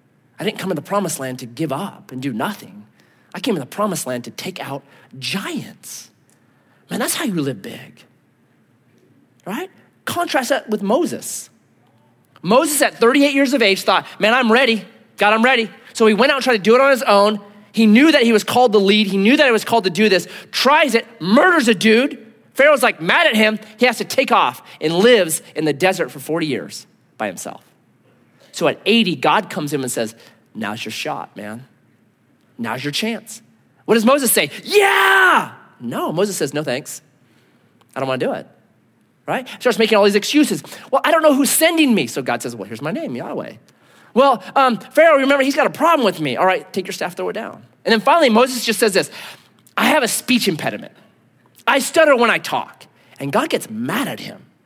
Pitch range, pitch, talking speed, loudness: 185-255 Hz, 215 Hz, 215 wpm, -16 LUFS